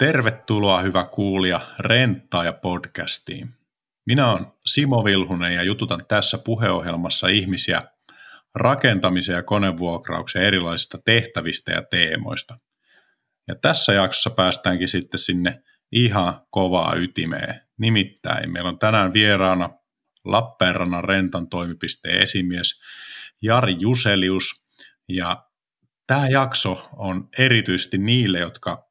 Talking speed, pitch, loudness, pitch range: 100 wpm, 95 Hz, -20 LUFS, 90-115 Hz